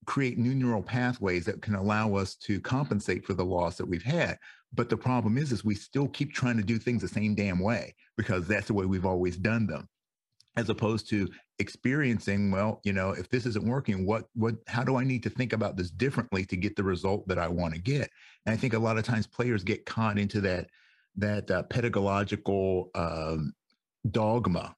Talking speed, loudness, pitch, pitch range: 215 wpm, -30 LUFS, 105 Hz, 95-120 Hz